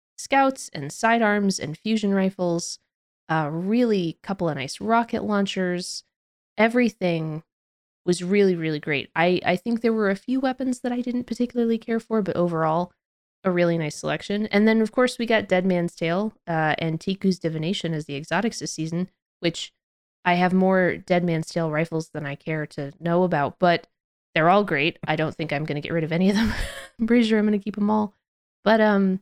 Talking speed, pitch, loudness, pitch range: 195 wpm, 180 Hz, -23 LUFS, 165-220 Hz